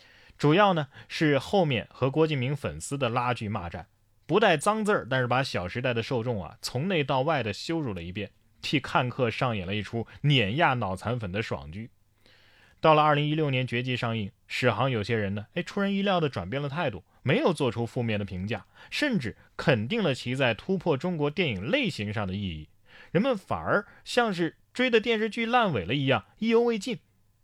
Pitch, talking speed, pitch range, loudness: 125 Hz, 295 characters per minute, 105-160 Hz, -27 LUFS